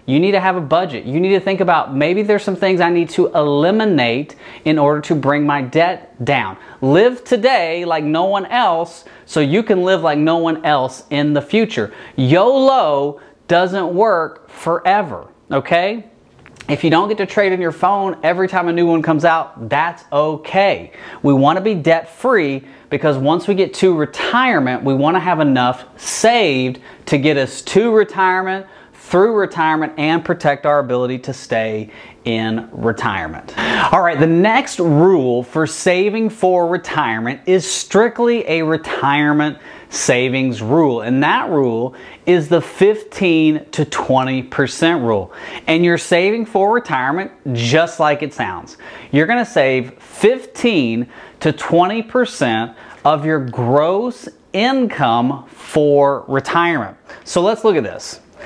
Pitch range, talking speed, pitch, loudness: 140-185 Hz, 150 wpm, 160 Hz, -16 LUFS